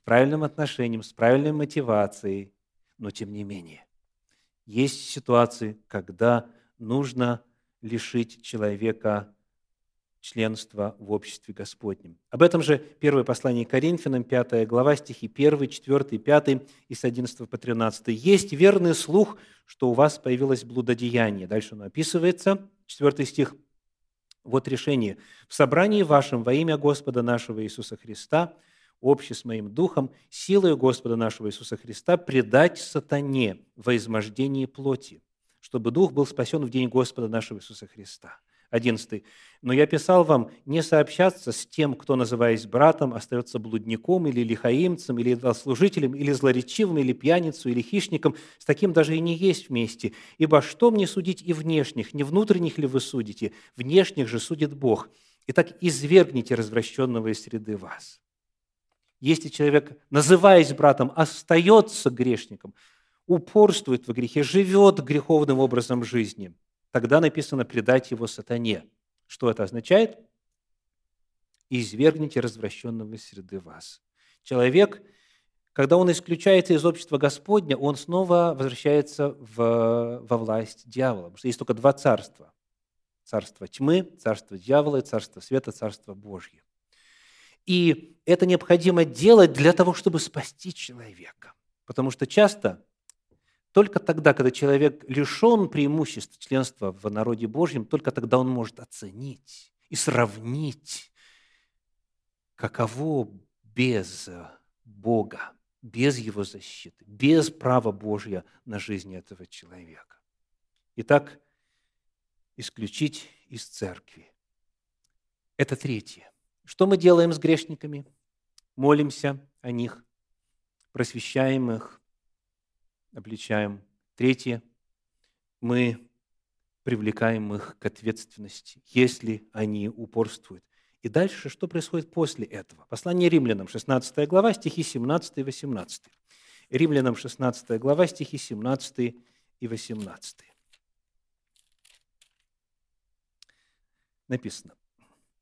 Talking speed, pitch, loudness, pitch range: 115 wpm, 125 Hz, -24 LUFS, 110-150 Hz